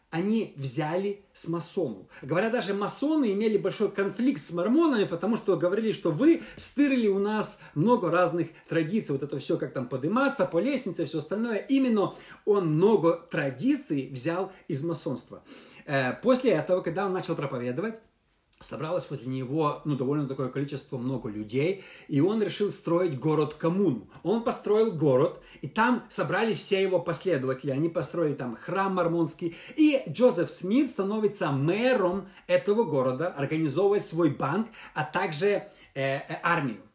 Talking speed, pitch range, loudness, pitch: 145 wpm, 155-205 Hz, -27 LUFS, 180 Hz